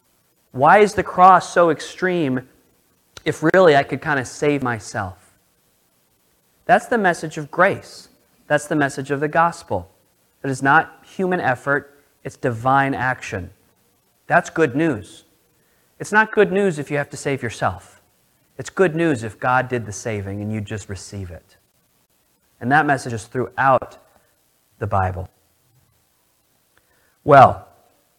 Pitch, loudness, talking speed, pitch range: 130 Hz, -19 LUFS, 145 wpm, 100-155 Hz